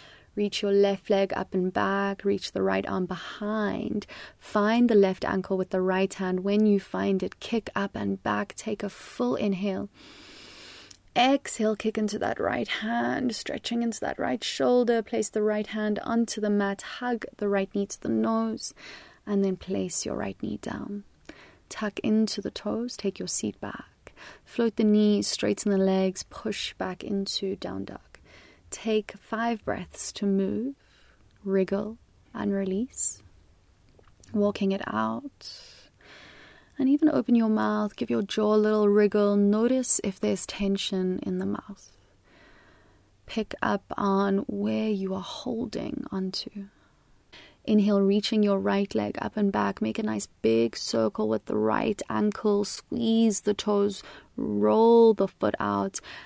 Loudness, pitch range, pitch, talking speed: -27 LUFS, 190-220 Hz, 200 Hz, 155 wpm